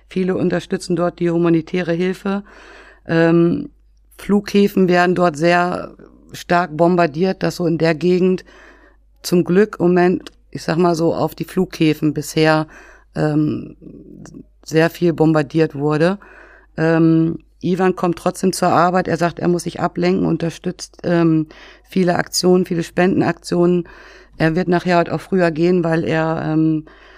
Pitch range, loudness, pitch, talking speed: 165-180 Hz, -17 LUFS, 170 Hz, 135 wpm